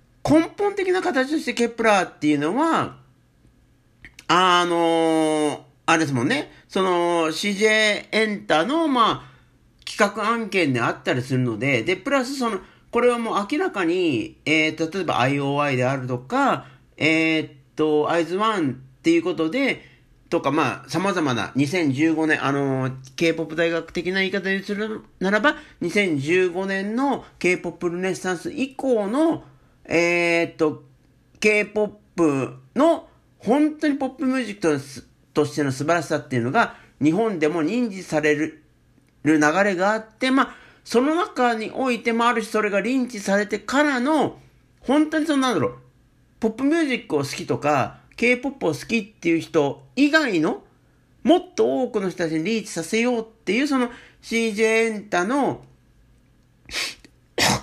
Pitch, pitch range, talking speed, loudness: 195 Hz, 155-245 Hz, 295 characters per minute, -22 LUFS